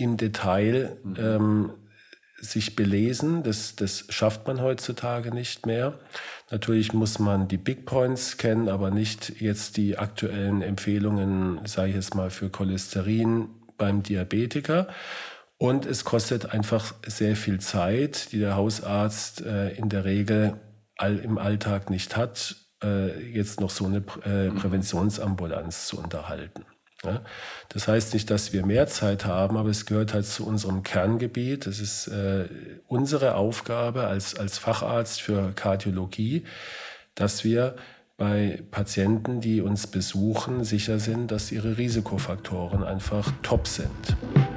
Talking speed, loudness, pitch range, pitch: 135 wpm, -27 LUFS, 100-115 Hz, 105 Hz